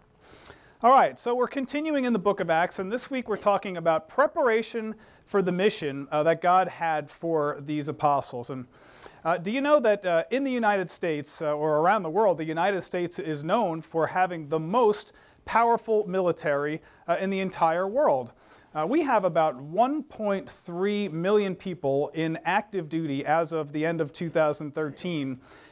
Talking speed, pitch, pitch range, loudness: 175 wpm, 175 Hz, 155-210 Hz, -26 LUFS